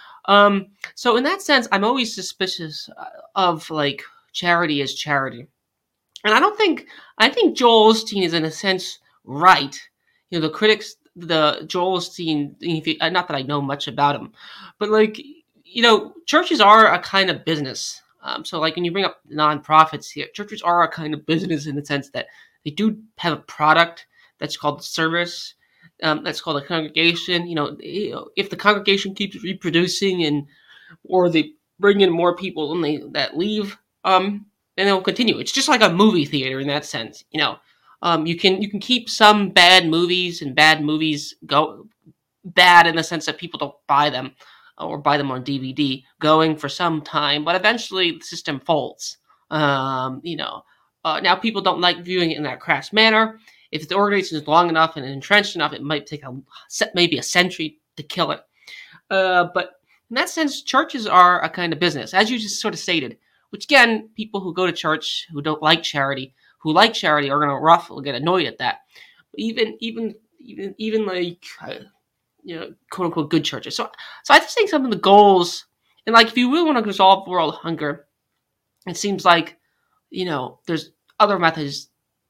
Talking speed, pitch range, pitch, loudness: 190 wpm, 150-205 Hz, 175 Hz, -18 LUFS